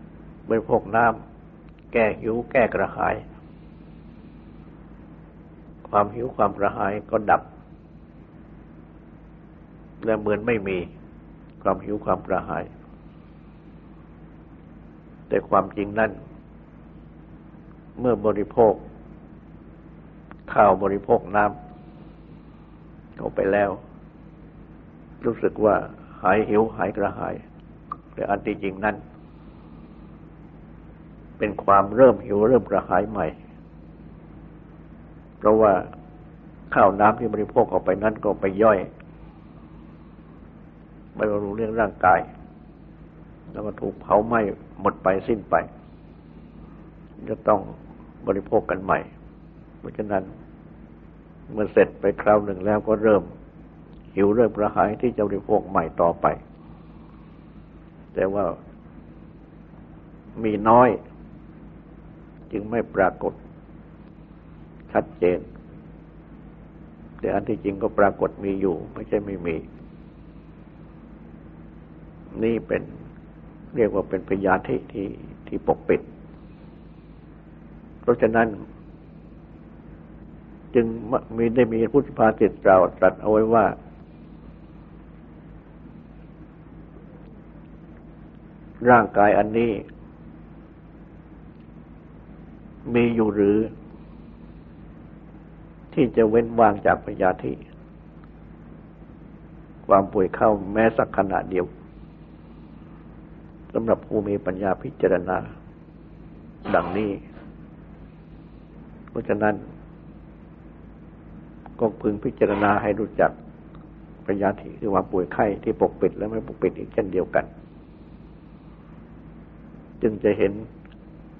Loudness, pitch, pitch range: -22 LUFS, 100 Hz, 80-110 Hz